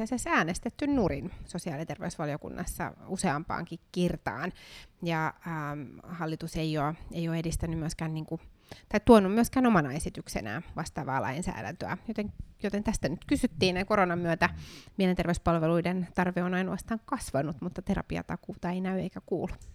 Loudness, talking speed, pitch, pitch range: -31 LUFS, 130 wpm, 175 Hz, 160-190 Hz